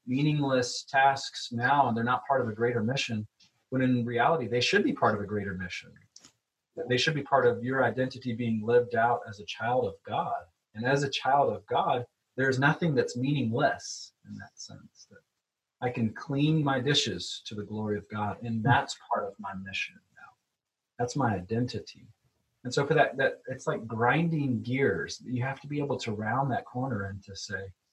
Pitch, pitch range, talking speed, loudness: 125 Hz, 115-135 Hz, 200 wpm, -29 LUFS